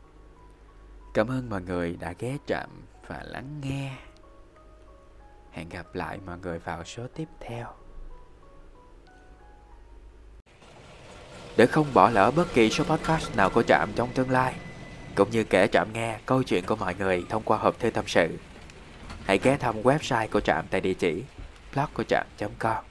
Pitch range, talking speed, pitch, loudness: 90-130 Hz, 160 wpm, 110 Hz, -26 LUFS